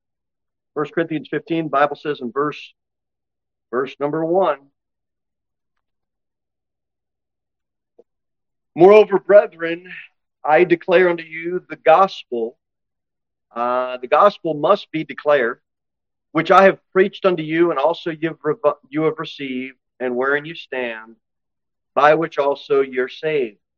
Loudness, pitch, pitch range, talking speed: -18 LUFS, 150 Hz, 120-165 Hz, 120 wpm